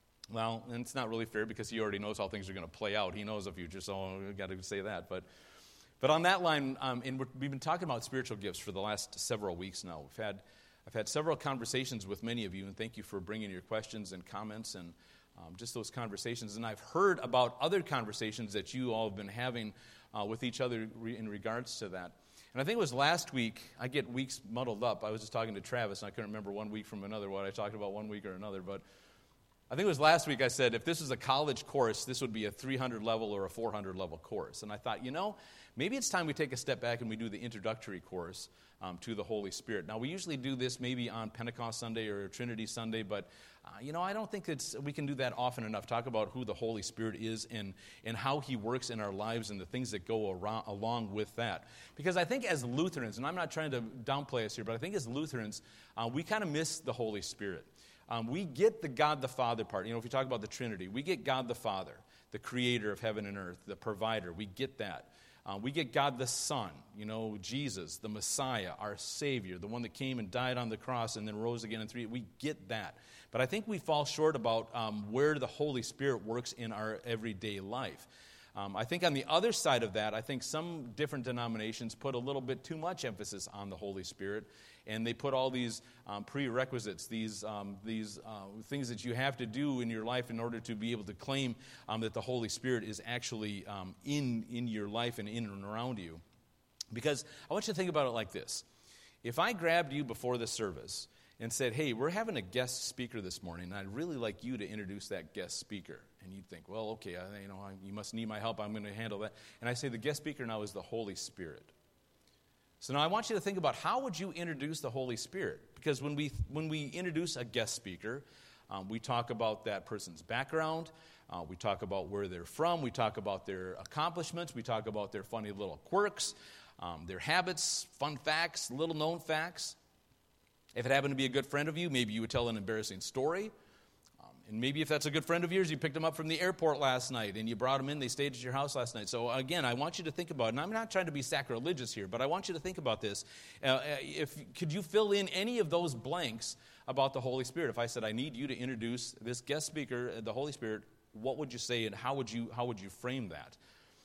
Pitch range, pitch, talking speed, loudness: 110-140 Hz, 120 Hz, 250 wpm, -37 LUFS